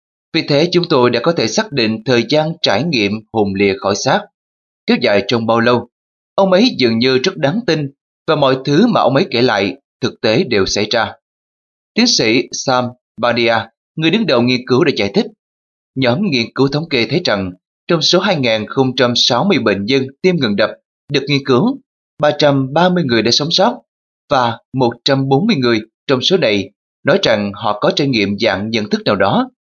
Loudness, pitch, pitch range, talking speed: -14 LUFS, 130 Hz, 115-160 Hz, 190 wpm